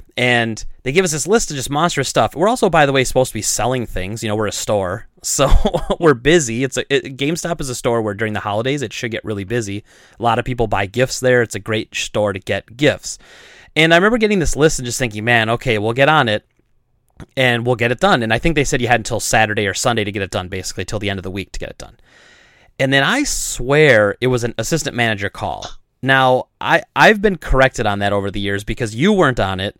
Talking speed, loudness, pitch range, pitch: 260 wpm, -16 LUFS, 110-140 Hz, 120 Hz